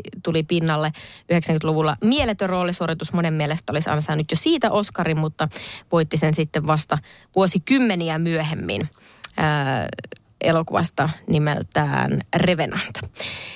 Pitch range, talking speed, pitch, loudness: 155-175 Hz, 100 wpm, 160 Hz, -21 LUFS